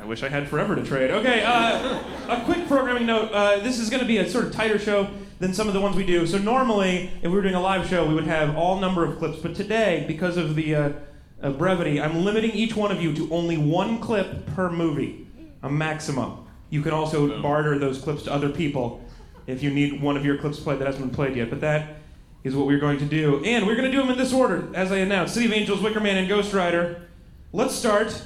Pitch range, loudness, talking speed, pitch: 150-210 Hz, -23 LUFS, 255 wpm, 175 Hz